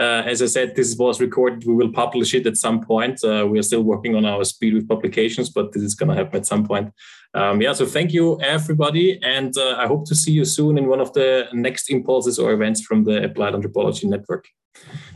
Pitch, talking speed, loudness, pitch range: 120 Hz, 240 wpm, -19 LUFS, 110-130 Hz